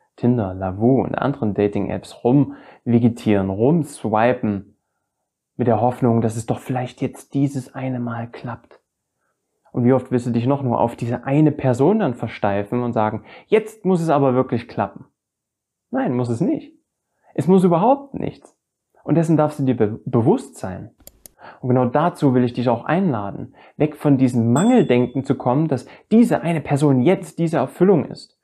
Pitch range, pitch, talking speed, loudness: 120-150 Hz, 130 Hz, 165 wpm, -19 LUFS